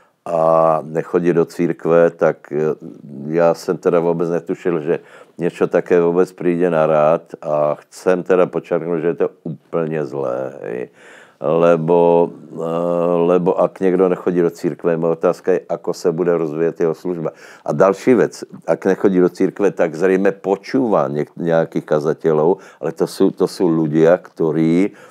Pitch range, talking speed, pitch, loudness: 80-90 Hz, 150 wpm, 85 Hz, -17 LUFS